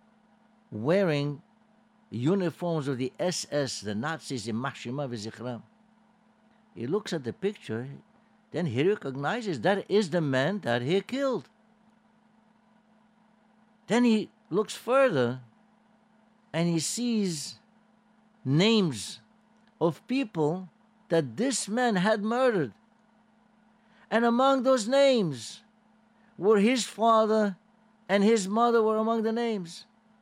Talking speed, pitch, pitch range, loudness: 105 wpm, 215 Hz, 170-230 Hz, -27 LUFS